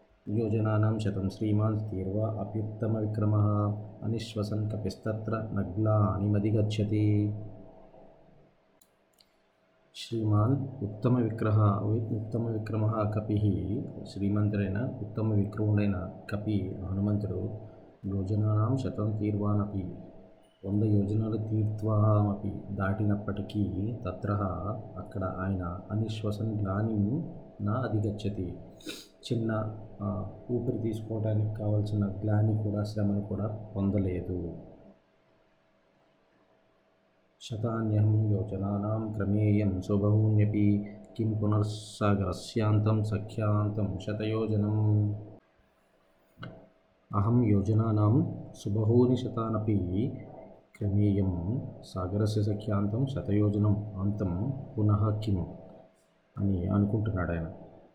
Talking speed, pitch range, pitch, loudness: 65 wpm, 100-110 Hz, 105 Hz, -30 LUFS